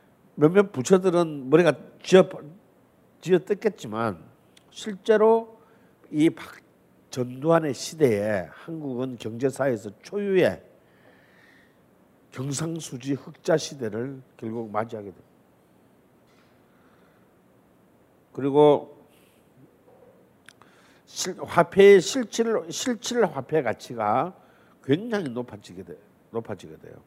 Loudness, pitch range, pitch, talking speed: -24 LUFS, 130-200 Hz, 155 Hz, 195 characters per minute